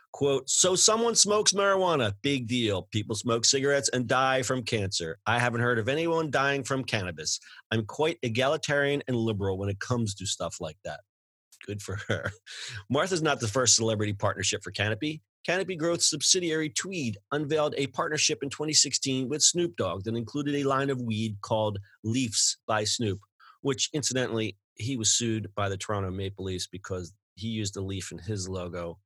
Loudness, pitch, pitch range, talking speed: -27 LUFS, 120 Hz, 105-145 Hz, 175 wpm